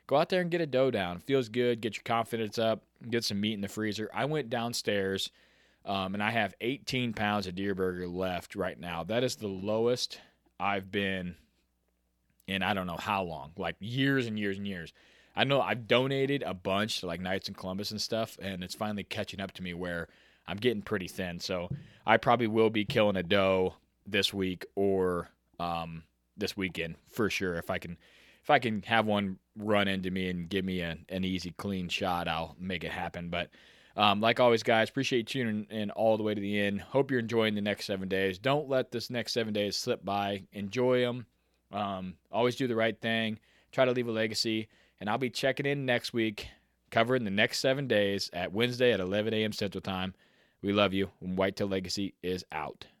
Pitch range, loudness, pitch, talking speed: 95-115 Hz, -31 LUFS, 100 Hz, 215 wpm